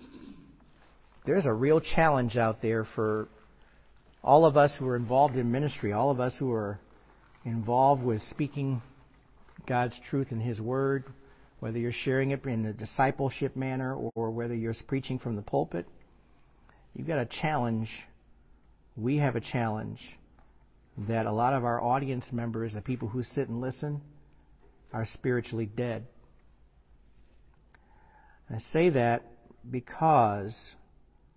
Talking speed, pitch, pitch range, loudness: 135 wpm, 120 Hz, 110-135 Hz, -29 LUFS